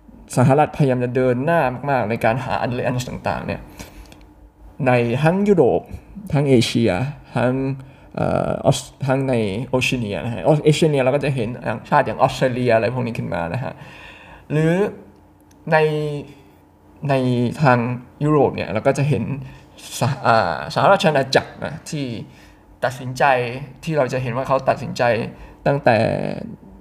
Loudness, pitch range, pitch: -19 LUFS, 115-140 Hz, 130 Hz